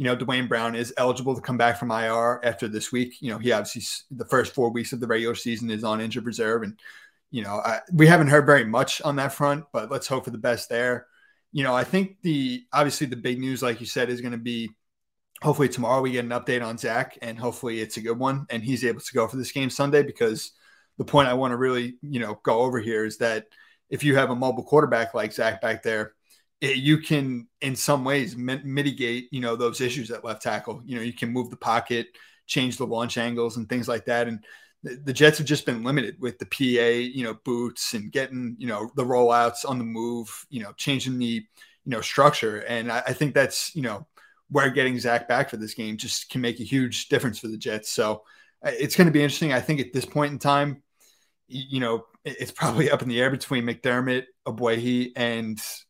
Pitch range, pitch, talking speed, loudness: 120-135 Hz, 125 Hz, 235 wpm, -24 LUFS